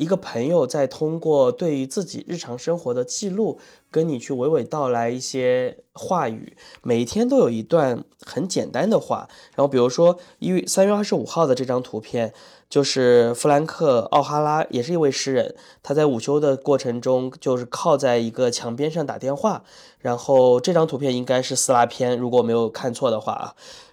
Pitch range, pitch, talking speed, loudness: 125-165 Hz, 135 Hz, 285 characters per minute, -21 LUFS